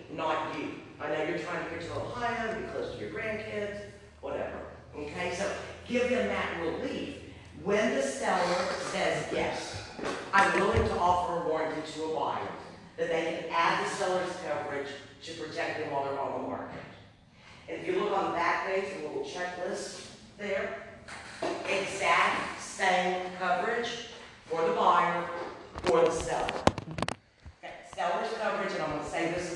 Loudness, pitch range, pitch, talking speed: -31 LUFS, 165-205 Hz, 180 Hz, 165 wpm